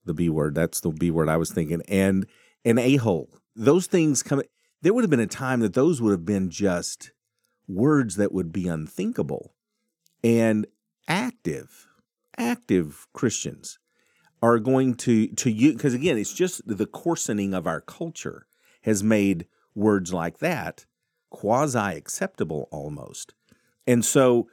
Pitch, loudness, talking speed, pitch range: 110 Hz, -24 LUFS, 150 wpm, 90-140 Hz